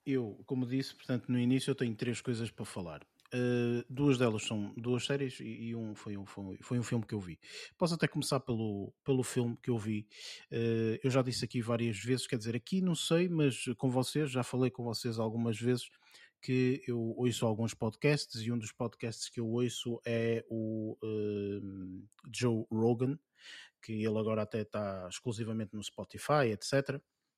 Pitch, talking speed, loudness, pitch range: 120 Hz, 185 wpm, -35 LUFS, 110-130 Hz